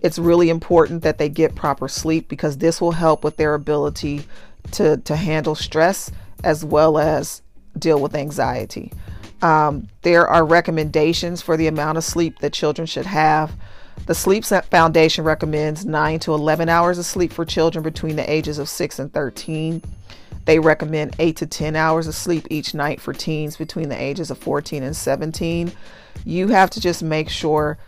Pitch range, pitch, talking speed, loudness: 150-165 Hz, 155 Hz, 175 wpm, -19 LUFS